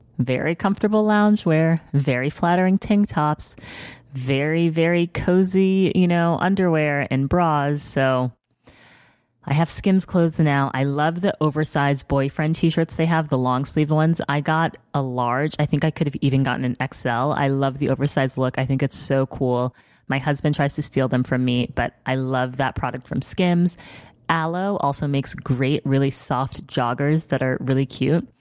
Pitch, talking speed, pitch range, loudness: 145 Hz, 175 wpm, 130-165 Hz, -21 LUFS